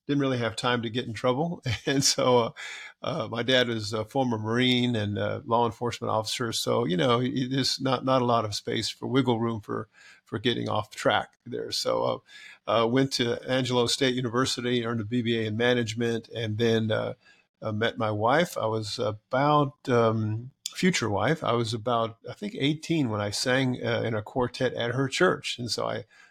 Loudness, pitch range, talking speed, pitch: -27 LUFS, 115-130 Hz, 200 wpm, 120 Hz